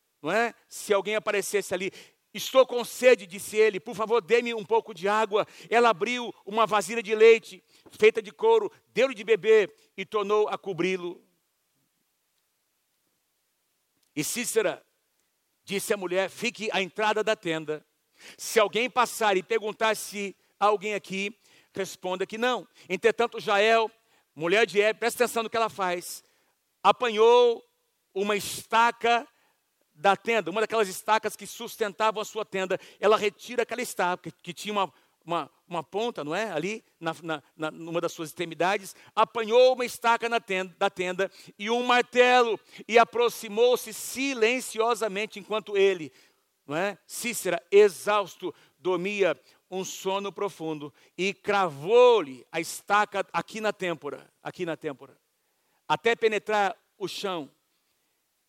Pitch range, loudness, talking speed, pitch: 190-230 Hz, -26 LUFS, 140 wpm, 210 Hz